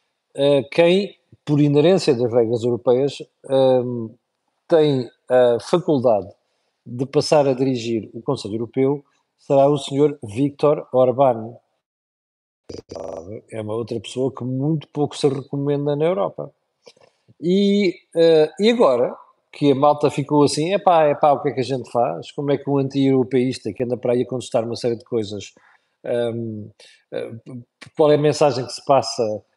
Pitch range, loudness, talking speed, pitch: 120-150 Hz, -19 LUFS, 145 wpm, 135 Hz